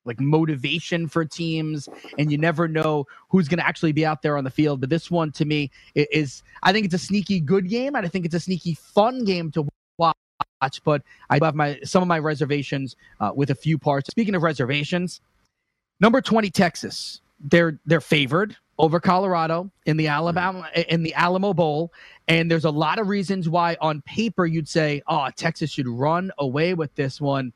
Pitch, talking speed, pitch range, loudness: 160 Hz, 200 wpm, 150-180 Hz, -22 LUFS